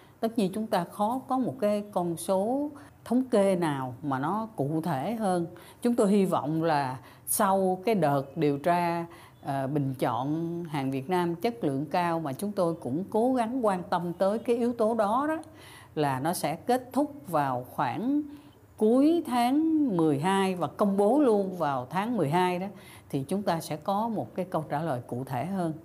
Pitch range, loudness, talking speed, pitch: 150-220 Hz, -28 LUFS, 190 wpm, 180 Hz